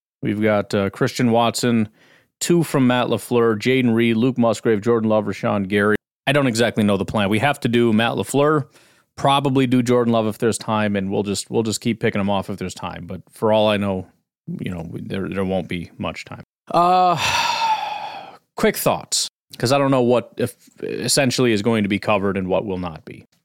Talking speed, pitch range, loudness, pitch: 205 wpm, 105-130 Hz, -19 LUFS, 115 Hz